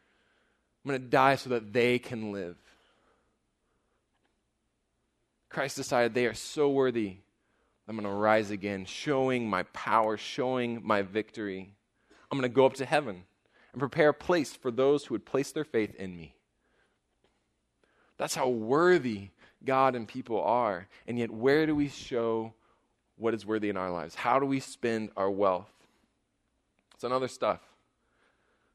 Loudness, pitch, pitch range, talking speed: -30 LUFS, 115 Hz, 105-135 Hz, 155 wpm